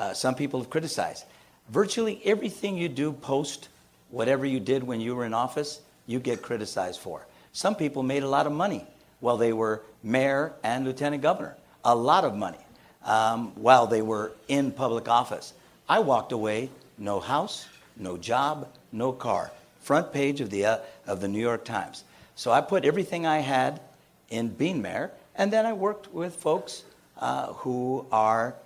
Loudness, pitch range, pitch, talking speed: -27 LUFS, 115-150 Hz, 130 Hz, 170 wpm